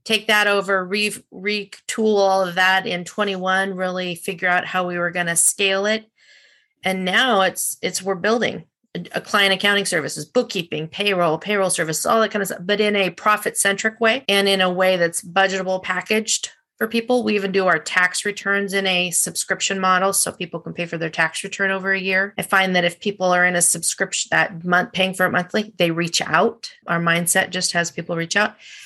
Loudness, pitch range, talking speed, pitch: -19 LUFS, 180-205 Hz, 210 wpm, 190 Hz